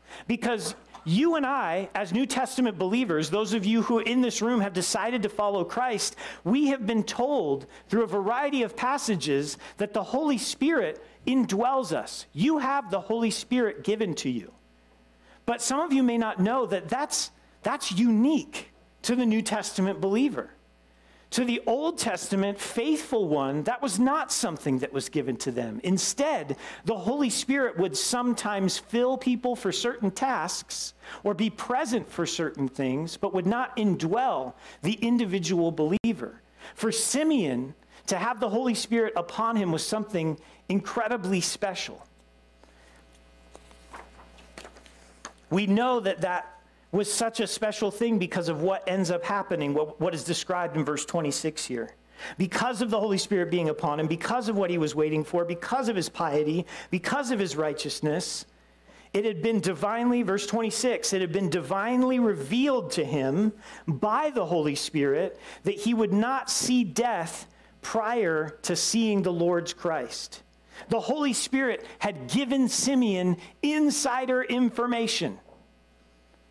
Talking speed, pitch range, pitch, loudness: 150 wpm, 165-240 Hz, 205 Hz, -27 LUFS